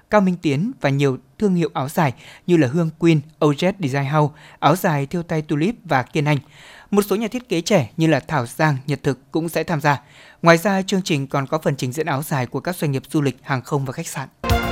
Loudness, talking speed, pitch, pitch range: -20 LUFS, 255 wpm, 155 Hz, 140-175 Hz